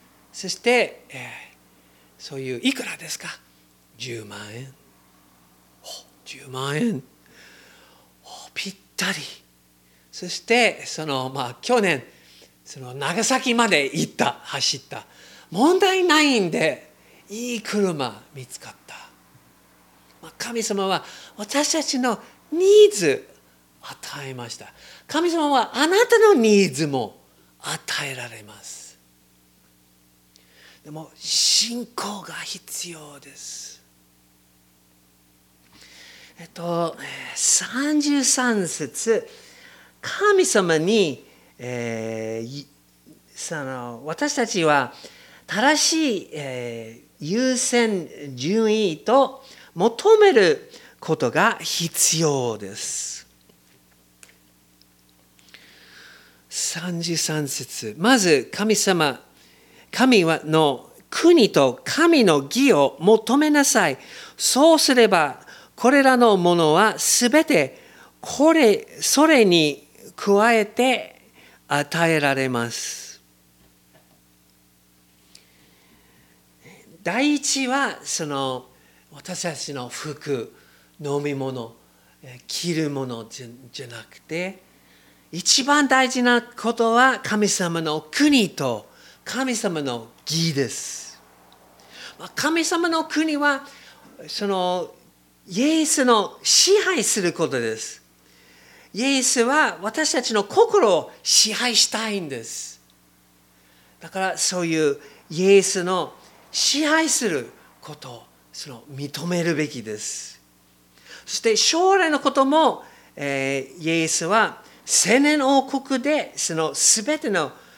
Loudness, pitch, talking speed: -20 LUFS, 165 Hz, 160 characters per minute